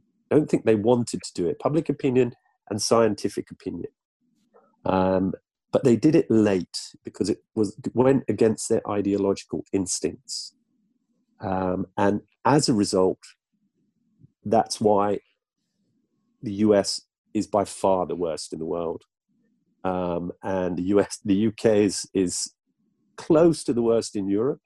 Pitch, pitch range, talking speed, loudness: 105 Hz, 95-120 Hz, 140 wpm, -24 LUFS